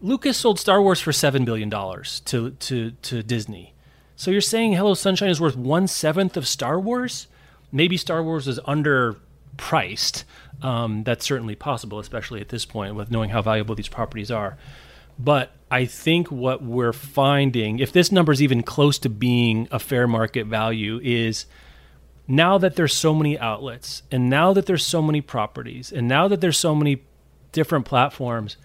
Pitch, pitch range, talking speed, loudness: 130 Hz, 115-160 Hz, 175 wpm, -21 LUFS